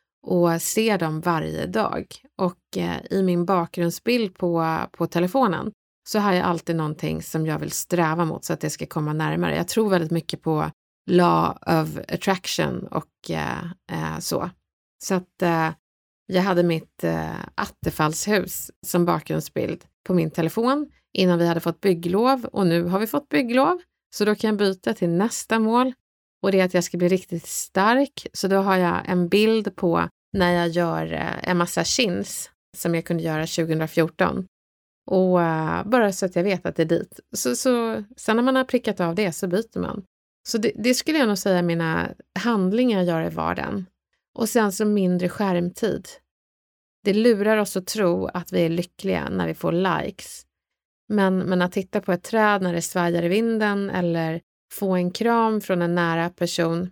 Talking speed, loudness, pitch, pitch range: 180 wpm, -23 LUFS, 180 Hz, 170-210 Hz